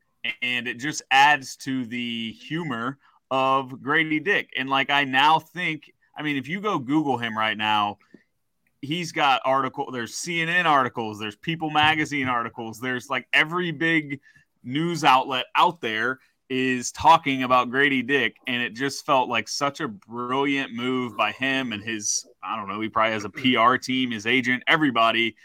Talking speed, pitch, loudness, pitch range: 170 wpm, 130 Hz, -23 LUFS, 120-150 Hz